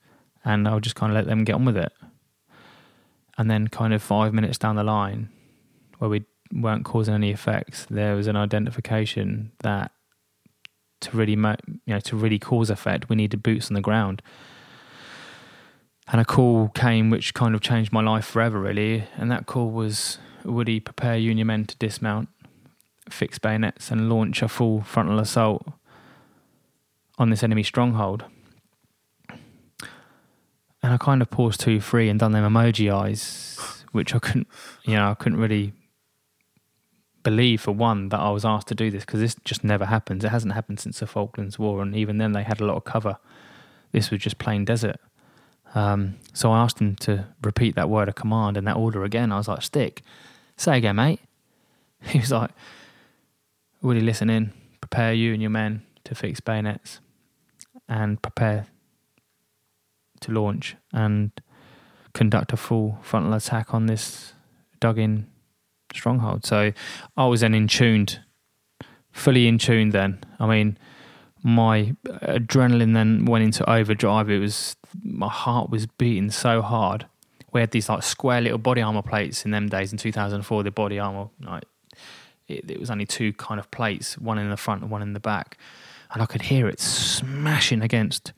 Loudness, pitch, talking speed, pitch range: -23 LUFS, 110 Hz, 175 wpm, 105-115 Hz